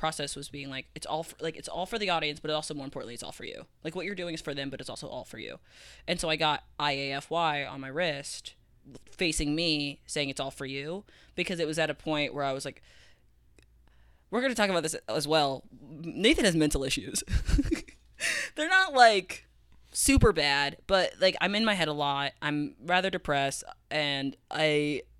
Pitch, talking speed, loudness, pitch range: 150 Hz, 210 wpm, -29 LUFS, 140-170 Hz